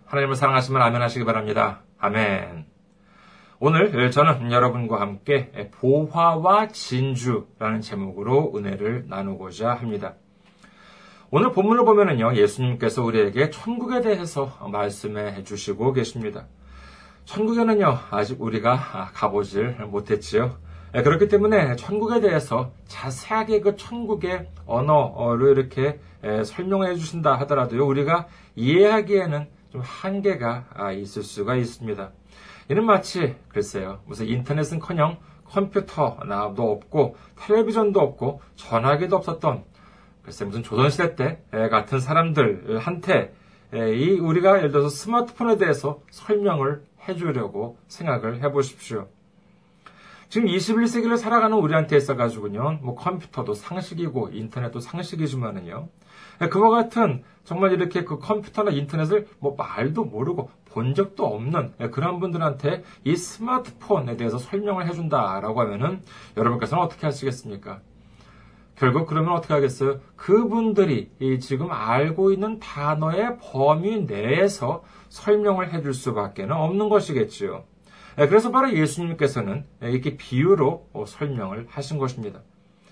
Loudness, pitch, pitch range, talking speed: -23 LUFS, 145 Hz, 120-190 Hz, 305 characters per minute